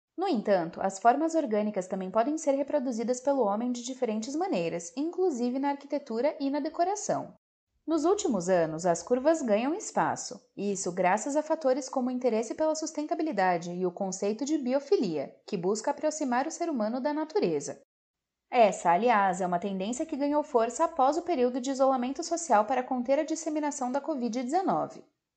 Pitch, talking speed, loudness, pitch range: 265 Hz, 165 wpm, -29 LUFS, 210-310 Hz